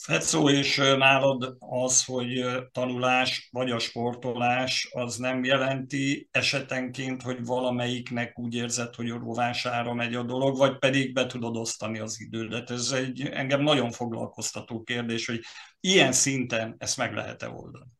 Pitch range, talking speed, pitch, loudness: 120-130 Hz, 145 wpm, 125 Hz, -26 LUFS